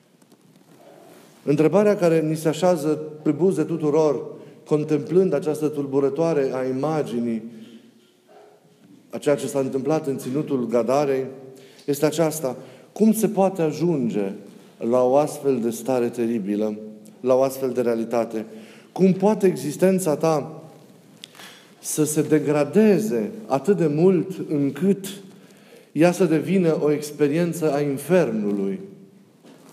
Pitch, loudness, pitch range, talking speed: 150 Hz, -22 LUFS, 130-170 Hz, 115 wpm